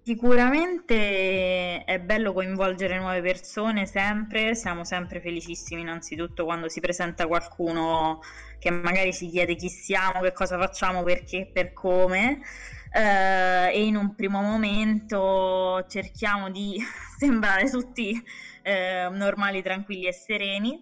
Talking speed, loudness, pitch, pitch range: 125 wpm, -25 LUFS, 190 Hz, 180-210 Hz